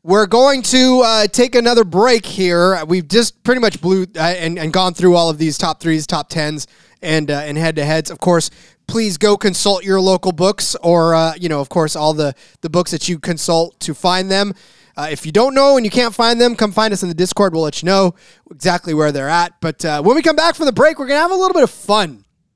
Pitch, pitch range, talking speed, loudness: 180 Hz, 160-220 Hz, 250 wpm, -14 LUFS